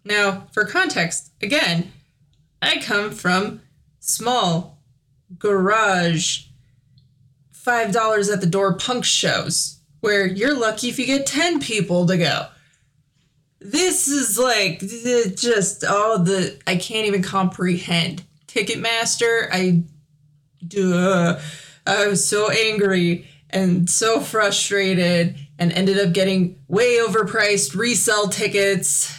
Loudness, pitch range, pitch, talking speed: -19 LUFS, 160-215 Hz, 190 Hz, 110 wpm